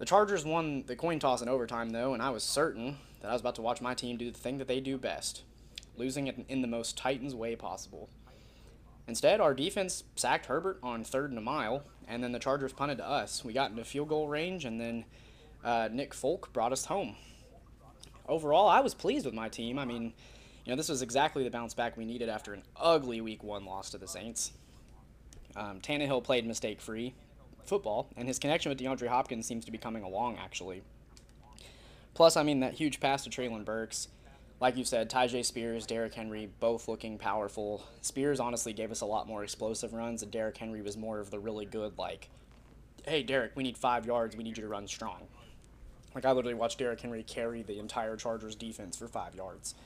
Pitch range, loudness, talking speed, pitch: 110-130 Hz, -34 LUFS, 210 wpm, 120 Hz